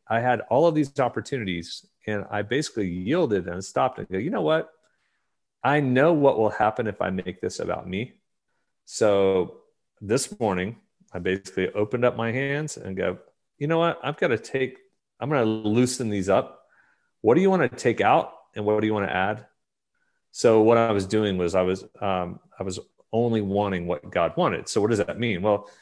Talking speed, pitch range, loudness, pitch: 205 wpm, 95-135 Hz, -24 LUFS, 110 Hz